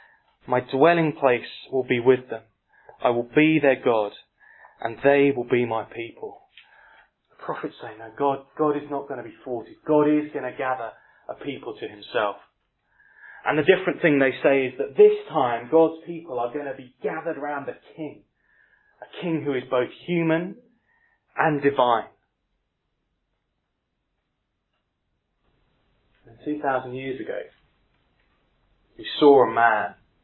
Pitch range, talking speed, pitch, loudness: 125-165 Hz, 150 wpm, 140 Hz, -23 LUFS